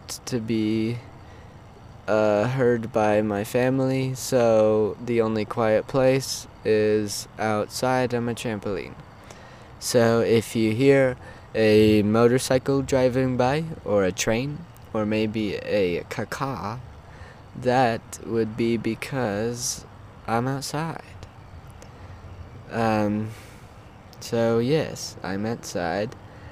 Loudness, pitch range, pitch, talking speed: -24 LUFS, 105-125 Hz, 115 Hz, 95 wpm